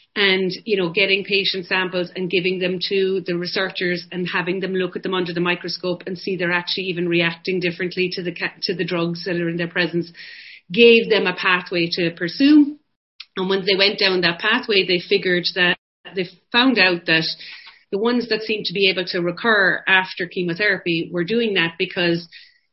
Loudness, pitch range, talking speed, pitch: -19 LUFS, 175-195 Hz, 195 wpm, 185 Hz